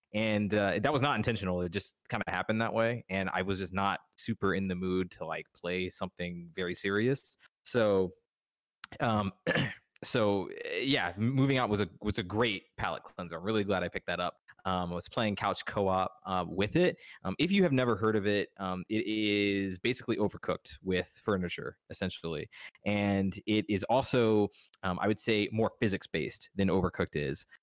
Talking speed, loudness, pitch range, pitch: 190 wpm, -32 LUFS, 95-110 Hz, 100 Hz